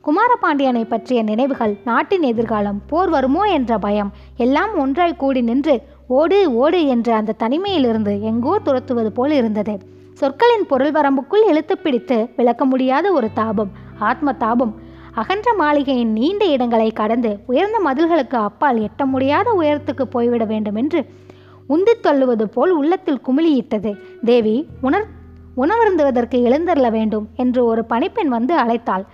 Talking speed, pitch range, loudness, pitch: 125 wpm, 230-305 Hz, -17 LUFS, 260 Hz